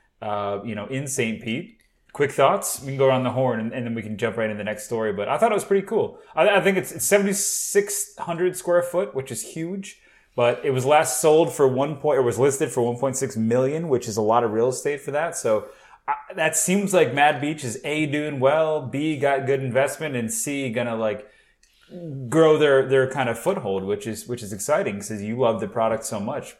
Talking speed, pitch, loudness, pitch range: 240 wpm, 135 Hz, -22 LUFS, 115-165 Hz